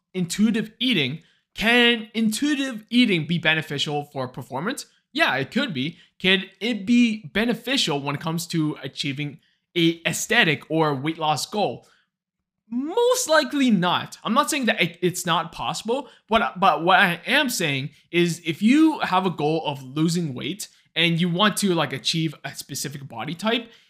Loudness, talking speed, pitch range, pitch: -22 LUFS, 160 wpm, 155-230 Hz, 175 Hz